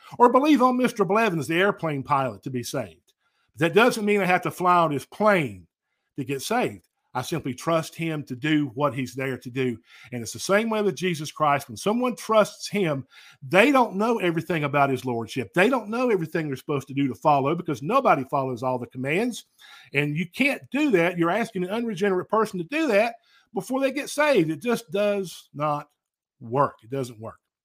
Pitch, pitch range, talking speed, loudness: 165 Hz, 135-210 Hz, 205 wpm, -24 LUFS